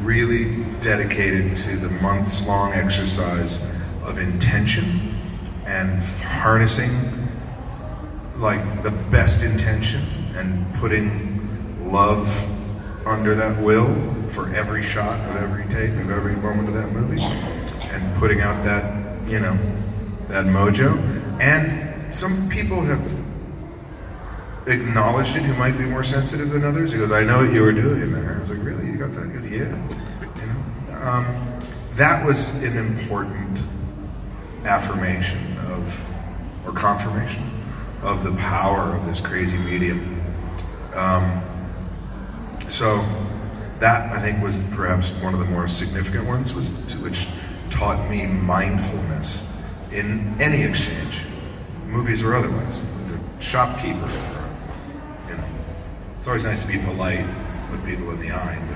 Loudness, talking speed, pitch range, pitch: -22 LUFS, 130 wpm, 95-110 Hz, 100 Hz